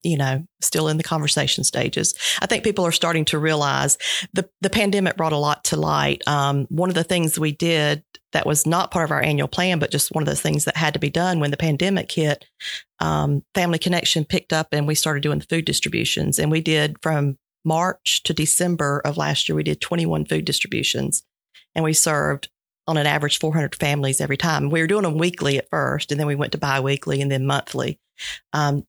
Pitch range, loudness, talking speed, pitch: 145-170 Hz, -21 LUFS, 225 wpm, 155 Hz